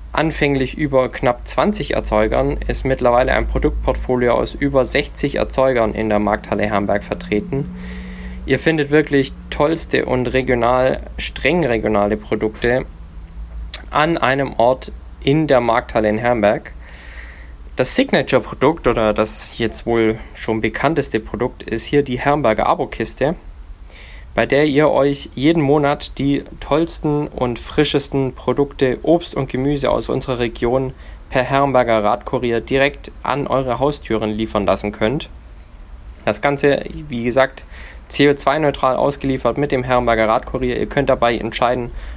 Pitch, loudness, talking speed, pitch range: 120 Hz, -18 LUFS, 130 wpm, 105-140 Hz